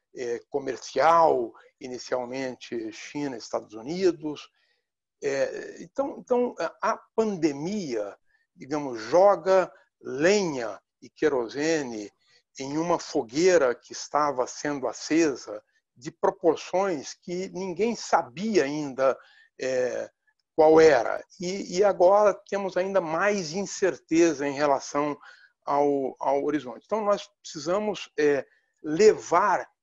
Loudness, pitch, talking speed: -26 LUFS, 185 Hz, 100 wpm